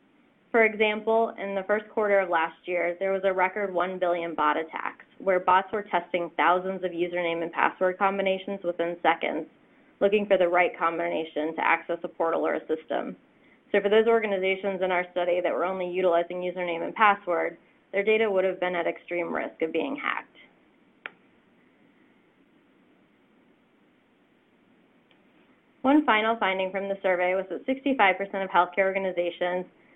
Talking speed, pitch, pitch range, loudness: 155 wpm, 190 Hz, 175-215 Hz, -26 LUFS